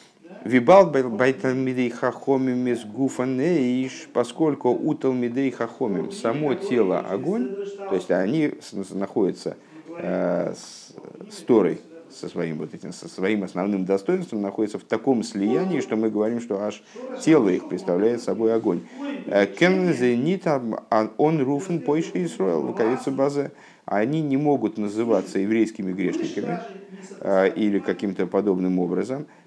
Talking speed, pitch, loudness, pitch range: 115 wpm, 125 Hz, -23 LUFS, 105-150 Hz